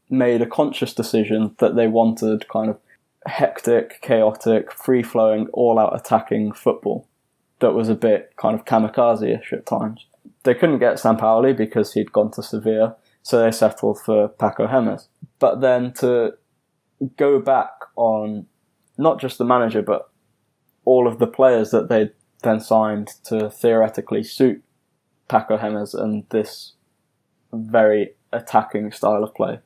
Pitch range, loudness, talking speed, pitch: 110-125 Hz, -19 LUFS, 145 wpm, 110 Hz